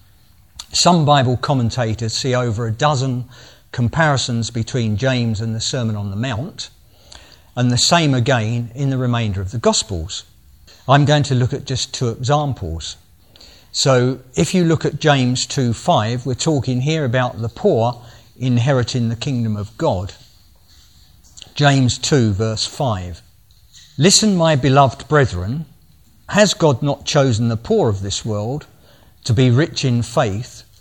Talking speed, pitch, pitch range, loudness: 140 wpm, 125 Hz, 110-140 Hz, -17 LUFS